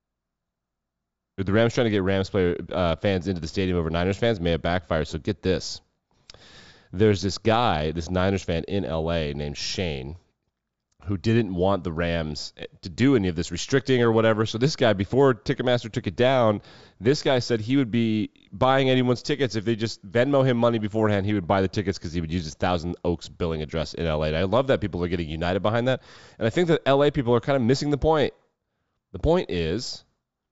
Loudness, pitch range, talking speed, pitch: -24 LUFS, 85-120 Hz, 215 wpm, 100 Hz